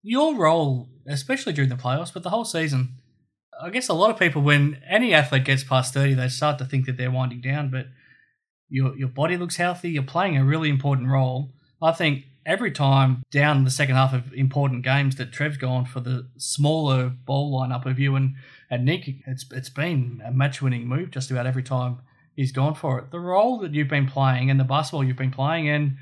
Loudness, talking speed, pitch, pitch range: -23 LUFS, 215 wpm, 135 Hz, 130-155 Hz